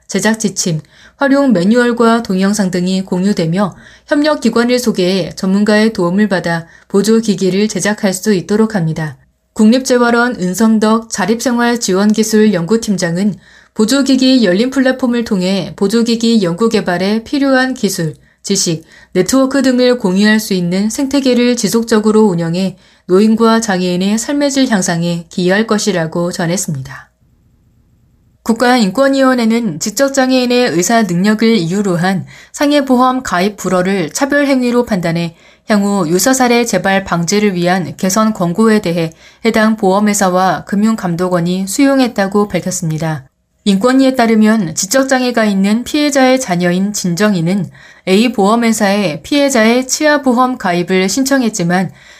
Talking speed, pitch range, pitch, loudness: 320 characters per minute, 185-240 Hz, 210 Hz, -12 LUFS